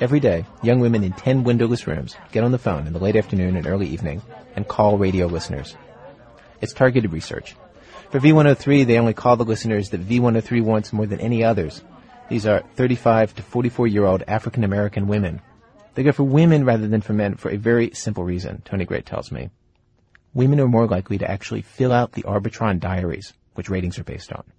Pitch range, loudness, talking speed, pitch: 100-120 Hz, -20 LUFS, 205 wpm, 110 Hz